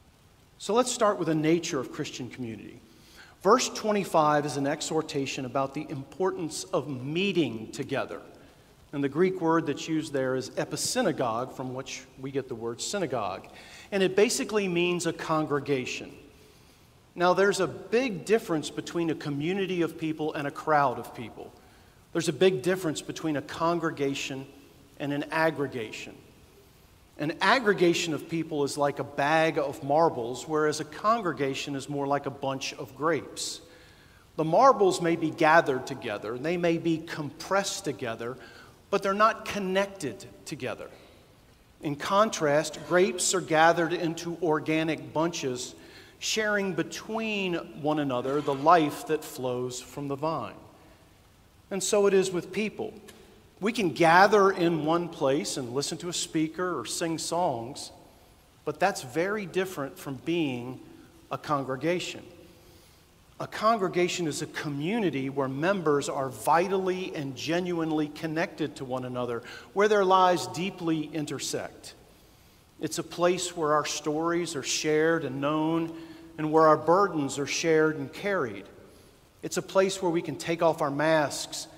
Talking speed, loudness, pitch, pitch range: 145 wpm, -28 LUFS, 155 Hz, 140-175 Hz